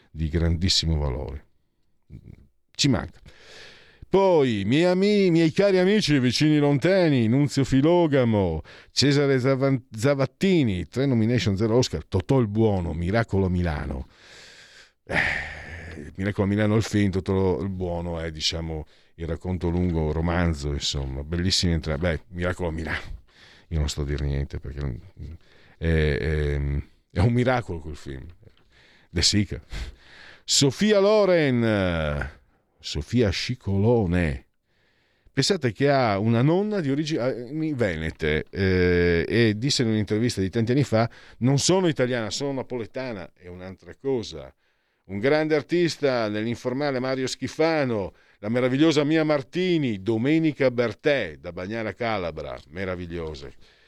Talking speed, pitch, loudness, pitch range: 125 wpm, 100 Hz, -23 LUFS, 85-135 Hz